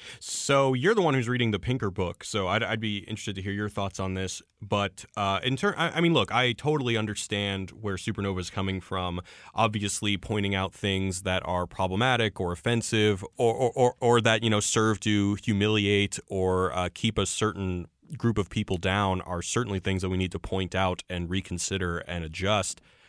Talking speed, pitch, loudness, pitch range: 200 wpm, 100 Hz, -27 LUFS, 95-115 Hz